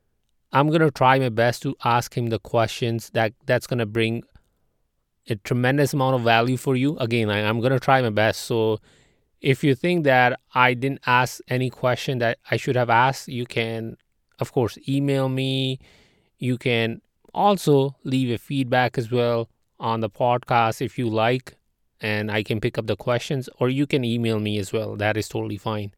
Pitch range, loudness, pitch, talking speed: 115-130 Hz, -22 LUFS, 125 Hz, 195 wpm